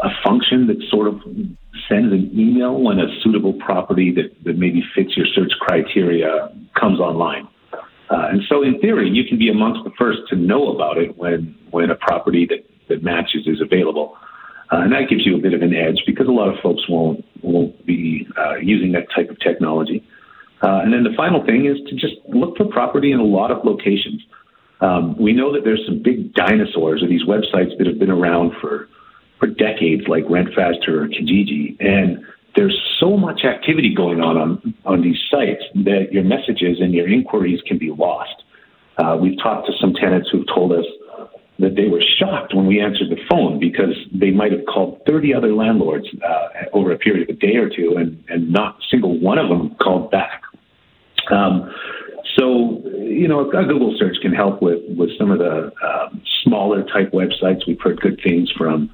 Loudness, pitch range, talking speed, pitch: -17 LUFS, 85-140 Hz, 200 wpm, 100 Hz